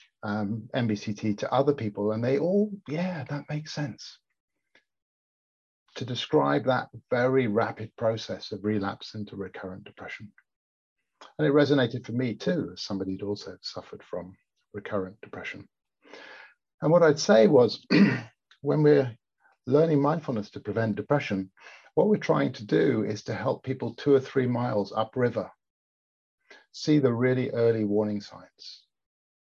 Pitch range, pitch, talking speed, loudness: 105-140 Hz, 115 Hz, 140 wpm, -26 LUFS